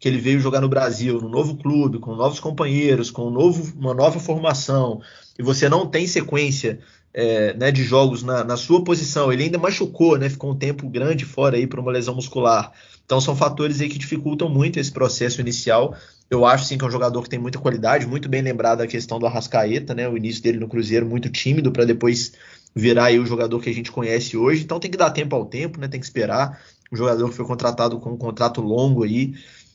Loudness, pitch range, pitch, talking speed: -20 LUFS, 120-145 Hz, 130 Hz, 230 wpm